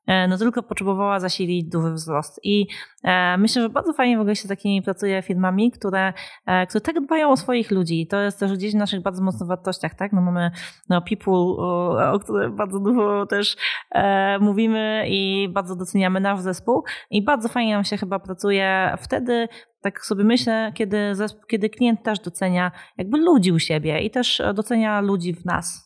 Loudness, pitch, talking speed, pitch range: -21 LUFS, 200 Hz, 185 wpm, 185-220 Hz